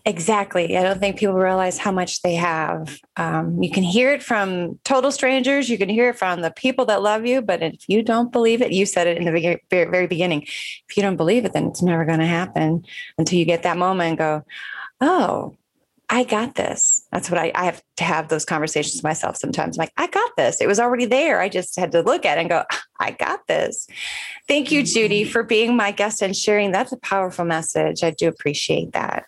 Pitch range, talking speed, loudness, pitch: 170-230 Hz, 230 wpm, -20 LUFS, 185 Hz